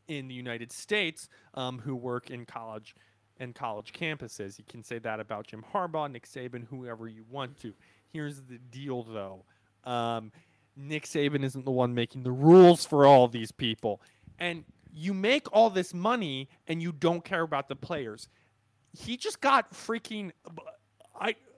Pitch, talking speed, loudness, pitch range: 135 Hz, 165 wpm, -28 LUFS, 115-165 Hz